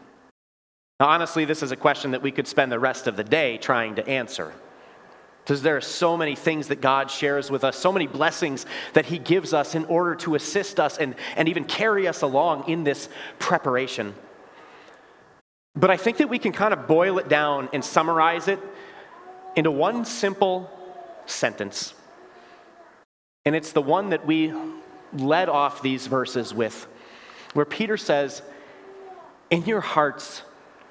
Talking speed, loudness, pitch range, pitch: 165 wpm, -23 LUFS, 145-200 Hz, 160 Hz